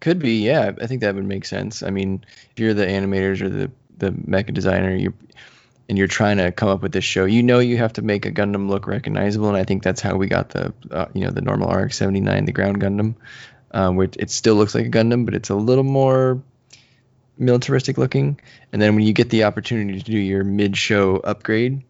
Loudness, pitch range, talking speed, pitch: -20 LUFS, 95-125 Hz, 230 wpm, 105 Hz